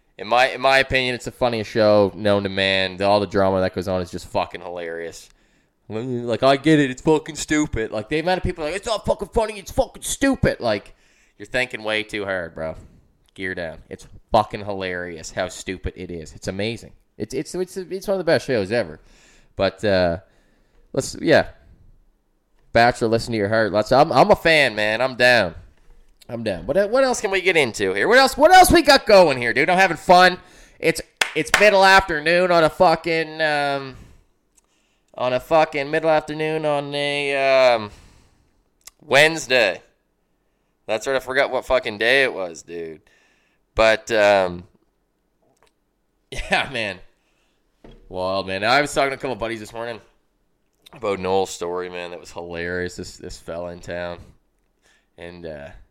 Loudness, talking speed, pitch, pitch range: -19 LUFS, 180 wpm, 115 Hz, 95-155 Hz